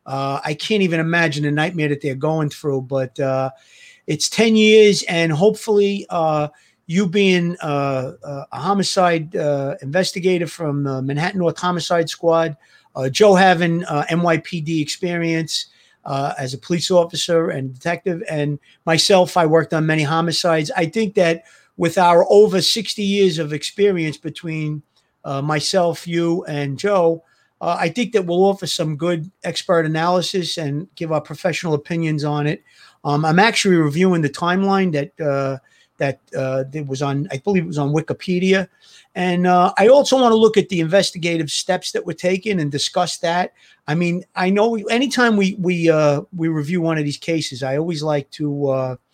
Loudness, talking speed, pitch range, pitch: -18 LUFS, 170 wpm, 150-185 Hz, 165 Hz